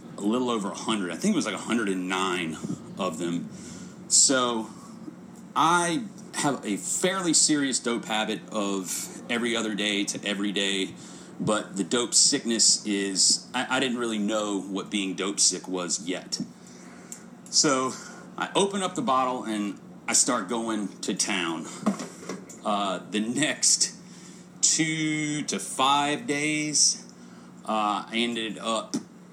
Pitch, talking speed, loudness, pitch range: 110 Hz, 135 wpm, -25 LUFS, 95-140 Hz